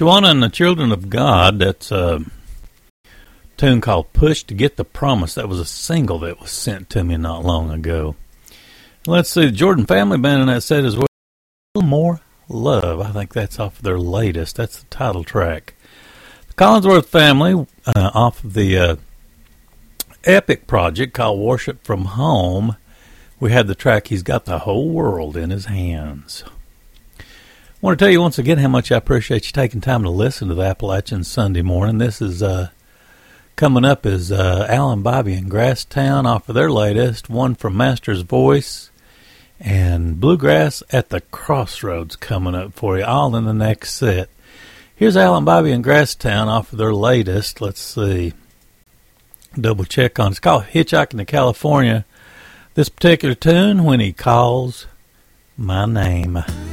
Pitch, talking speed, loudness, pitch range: 110 Hz, 170 wpm, -16 LUFS, 95-130 Hz